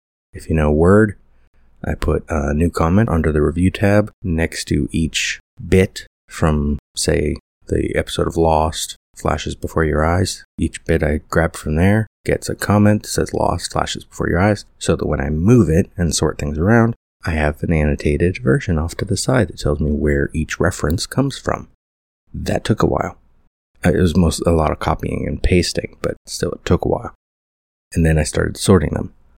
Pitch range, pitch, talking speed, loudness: 75-90 Hz, 80 Hz, 195 wpm, -18 LUFS